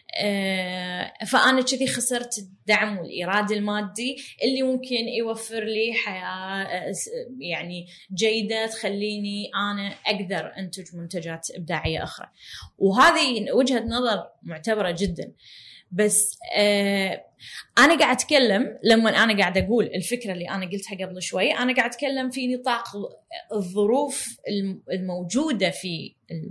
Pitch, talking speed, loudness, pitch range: 210 Hz, 110 wpm, -23 LUFS, 190-240 Hz